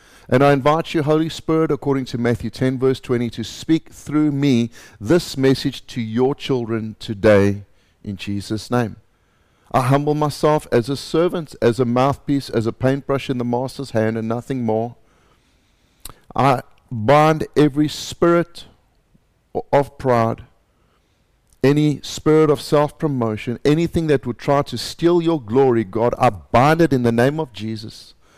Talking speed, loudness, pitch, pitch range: 150 wpm, -19 LUFS, 130 Hz, 115-145 Hz